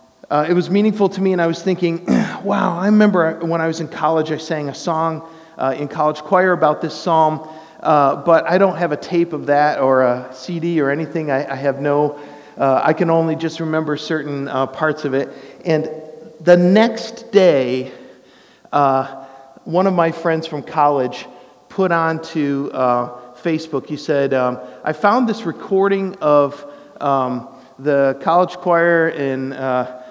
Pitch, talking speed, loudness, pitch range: 155 Hz, 175 wpm, -17 LUFS, 140-170 Hz